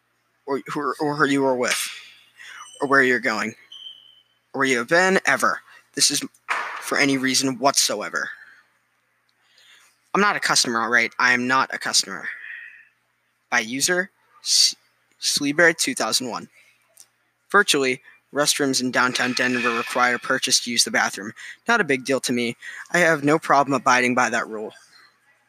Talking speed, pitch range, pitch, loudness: 150 wpm, 125-145 Hz, 135 Hz, -20 LUFS